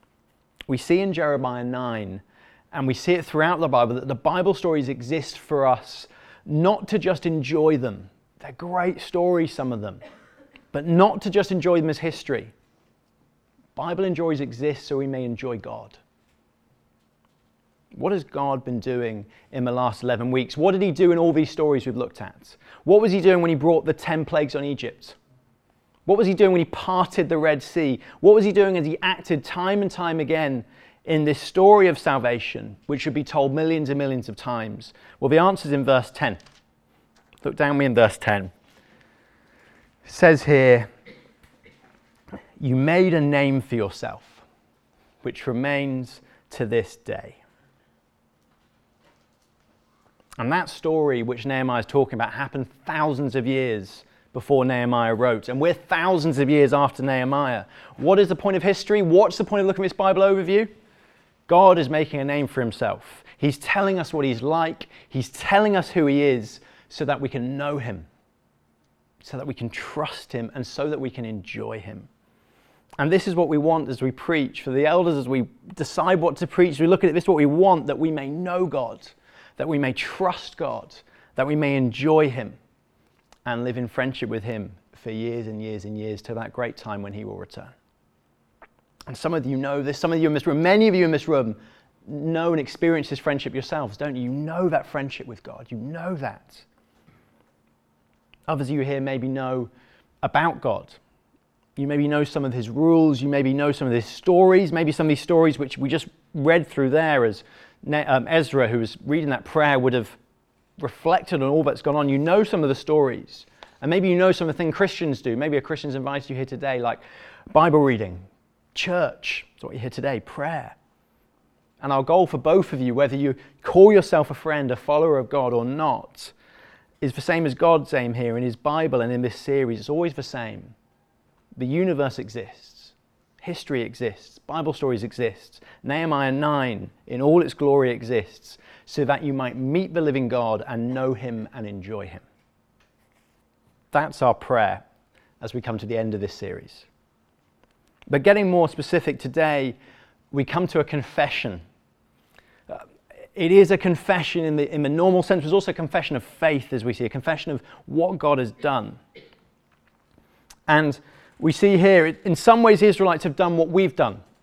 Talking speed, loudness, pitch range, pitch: 190 wpm, -22 LUFS, 125-165 Hz, 145 Hz